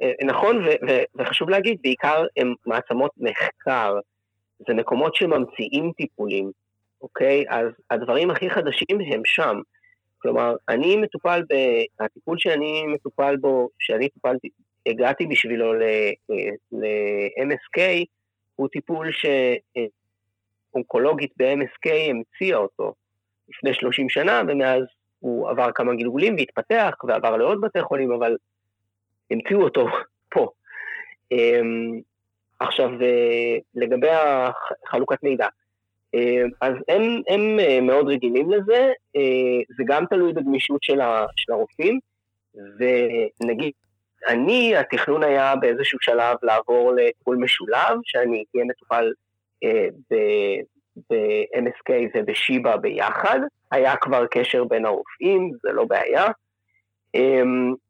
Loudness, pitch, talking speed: -21 LUFS, 130 Hz, 100 wpm